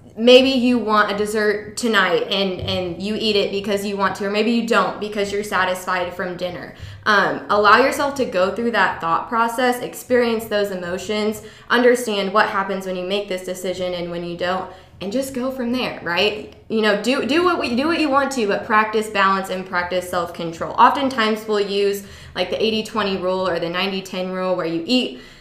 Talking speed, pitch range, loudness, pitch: 200 wpm, 185-230 Hz, -19 LUFS, 205 Hz